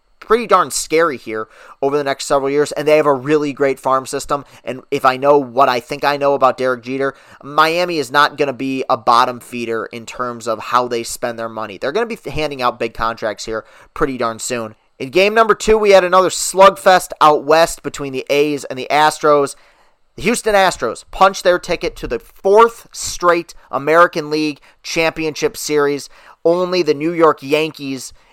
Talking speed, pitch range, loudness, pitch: 195 wpm, 130-165 Hz, -16 LUFS, 145 Hz